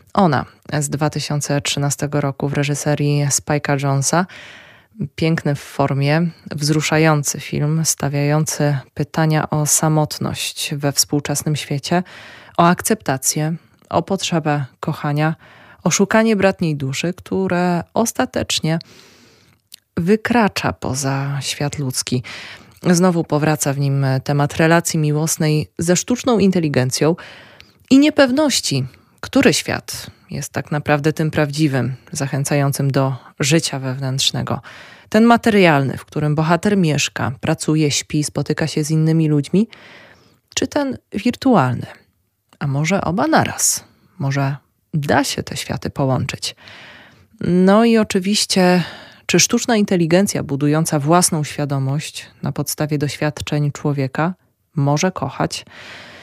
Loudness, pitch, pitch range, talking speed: -18 LUFS, 150 Hz, 140-175 Hz, 105 wpm